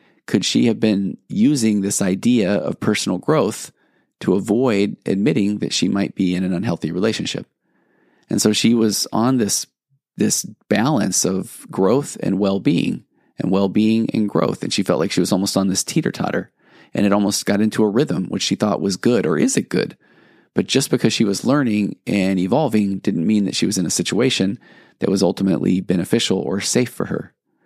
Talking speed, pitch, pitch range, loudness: 190 wpm, 100 Hz, 95-110 Hz, -19 LUFS